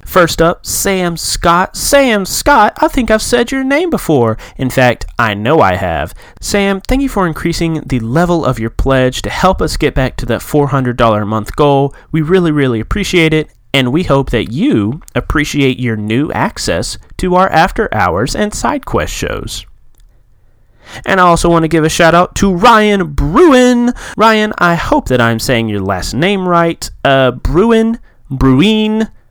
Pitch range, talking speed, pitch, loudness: 130-195 Hz, 180 wpm, 165 Hz, -12 LUFS